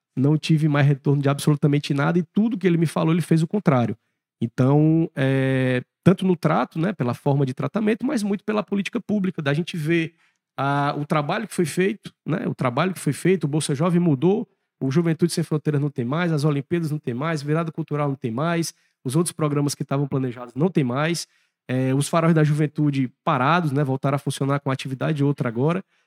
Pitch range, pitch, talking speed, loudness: 140-170 Hz, 155 Hz, 210 wpm, -22 LUFS